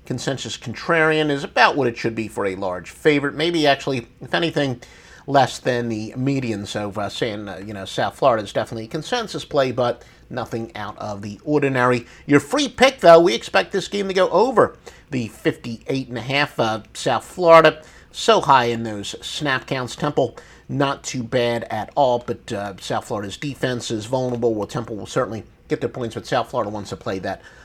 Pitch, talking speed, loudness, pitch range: 125 Hz, 190 wpm, -20 LUFS, 115-150 Hz